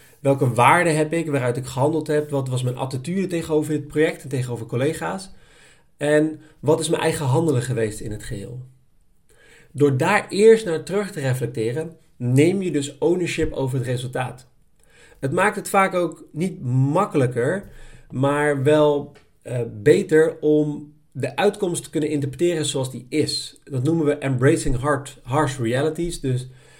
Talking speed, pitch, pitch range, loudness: 155 wpm, 150 Hz, 130-160 Hz, -21 LUFS